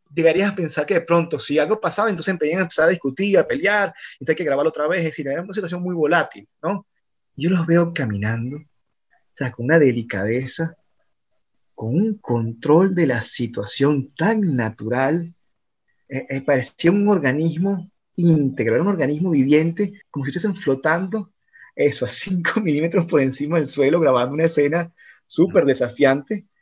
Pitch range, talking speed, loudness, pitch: 135-180 Hz, 160 wpm, -20 LUFS, 160 Hz